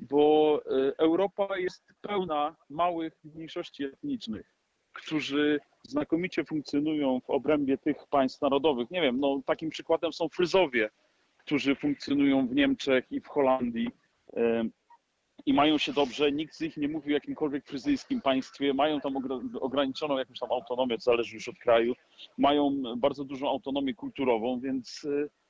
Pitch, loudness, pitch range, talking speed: 145 Hz, -29 LUFS, 135-165 Hz, 140 wpm